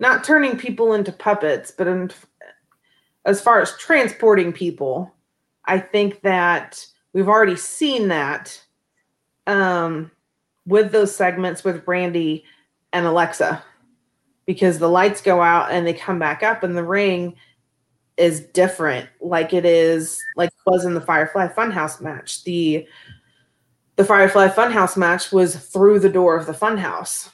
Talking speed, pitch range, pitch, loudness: 145 wpm, 170-200 Hz, 185 Hz, -18 LUFS